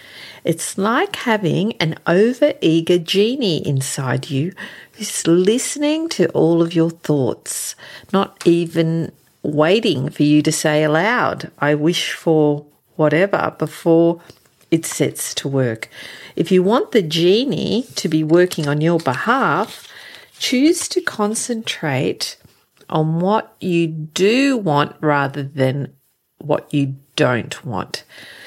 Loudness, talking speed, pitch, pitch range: -18 LUFS, 120 wpm, 165 Hz, 150-205 Hz